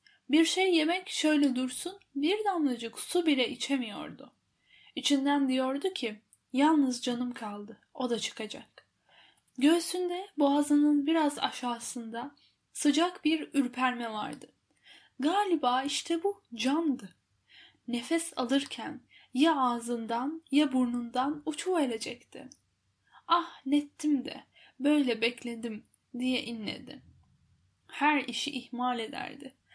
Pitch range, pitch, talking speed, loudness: 245-315 Hz, 275 Hz, 100 wpm, -30 LUFS